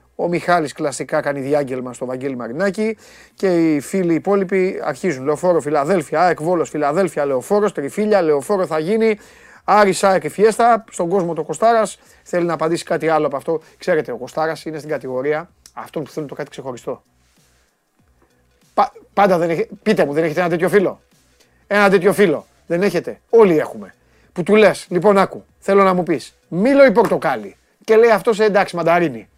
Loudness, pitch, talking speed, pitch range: -17 LUFS, 175 Hz, 175 wpm, 150-205 Hz